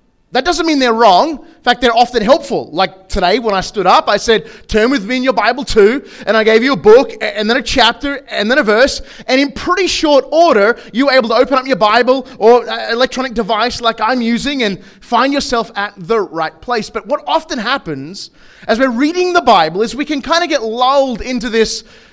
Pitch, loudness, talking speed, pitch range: 245 Hz, -13 LUFS, 225 wpm, 220-275 Hz